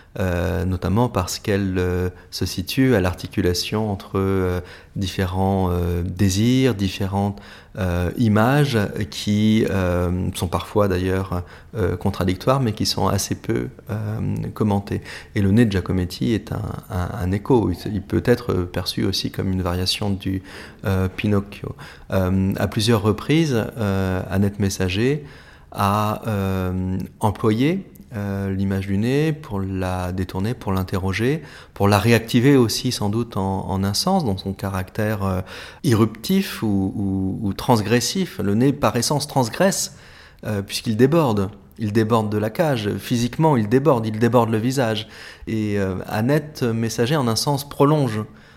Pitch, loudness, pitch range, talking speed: 100 Hz, -21 LUFS, 95-115 Hz, 145 wpm